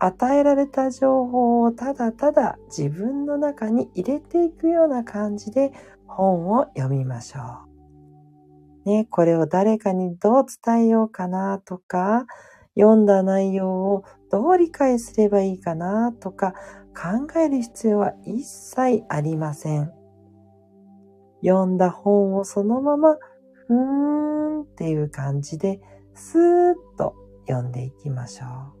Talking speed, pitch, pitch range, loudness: 245 characters per minute, 200 Hz, 155-260 Hz, -21 LUFS